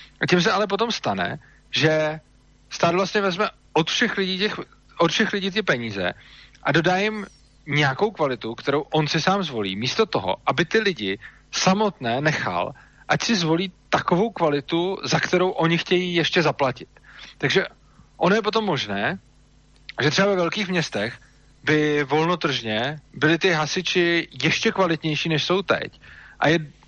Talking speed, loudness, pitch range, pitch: 150 wpm, -22 LUFS, 145-190 Hz, 165 Hz